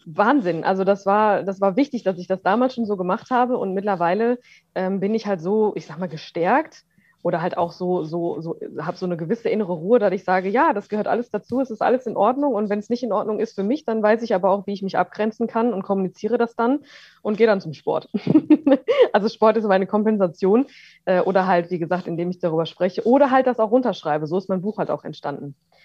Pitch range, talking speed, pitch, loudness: 180-230 Hz, 245 wpm, 200 Hz, -21 LUFS